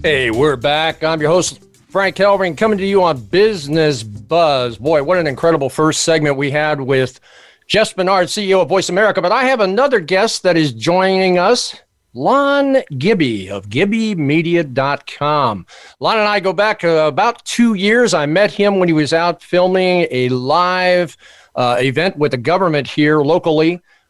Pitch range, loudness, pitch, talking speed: 150-195 Hz, -14 LUFS, 170 Hz, 170 wpm